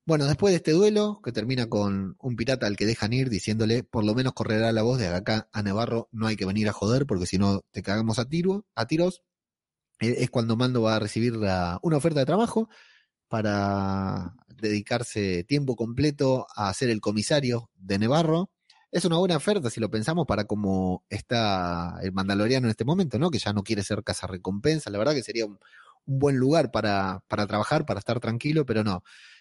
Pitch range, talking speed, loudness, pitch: 100-135 Hz, 205 wpm, -26 LUFS, 115 Hz